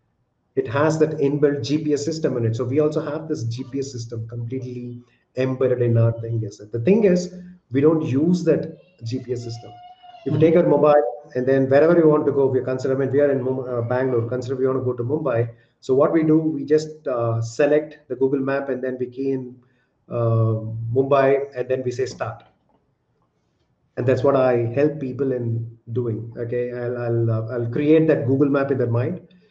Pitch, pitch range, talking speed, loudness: 130 Hz, 120-150 Hz, 200 wpm, -21 LUFS